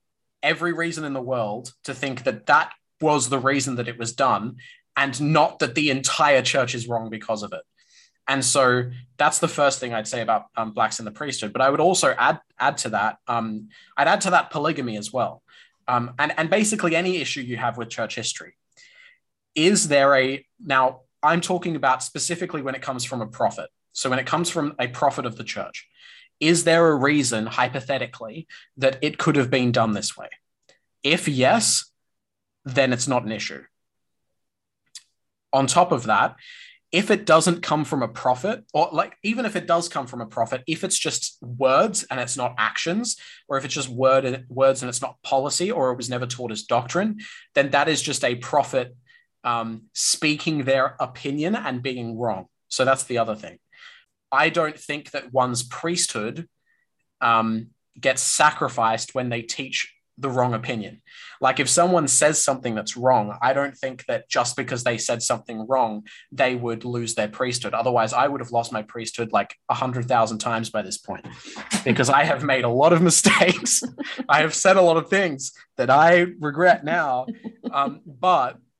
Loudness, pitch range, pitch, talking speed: -22 LUFS, 120-160 Hz, 135 Hz, 190 wpm